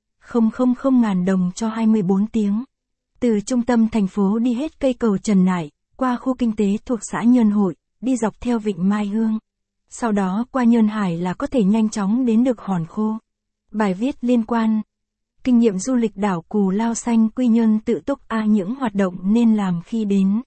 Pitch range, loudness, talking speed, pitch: 205-240 Hz, -20 LUFS, 205 wpm, 220 Hz